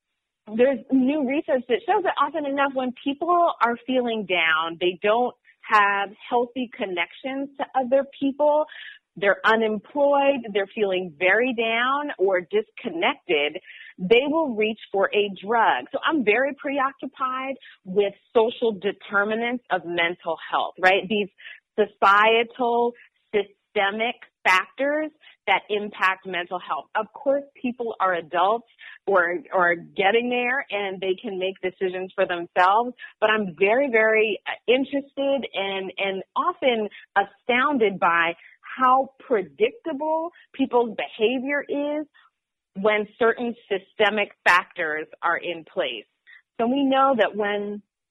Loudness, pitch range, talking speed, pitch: -23 LUFS, 195-270 Hz, 120 wpm, 225 Hz